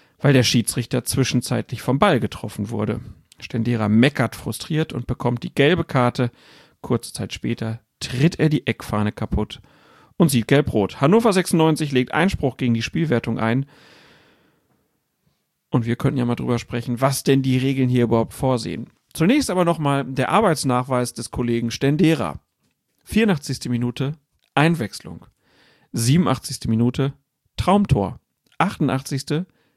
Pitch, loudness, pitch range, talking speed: 130 Hz, -21 LUFS, 120-150 Hz, 130 wpm